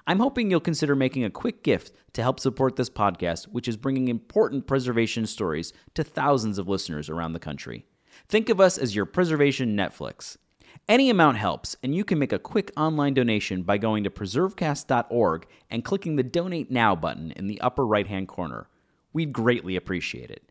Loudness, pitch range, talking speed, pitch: -25 LUFS, 100-150 Hz, 185 wpm, 125 Hz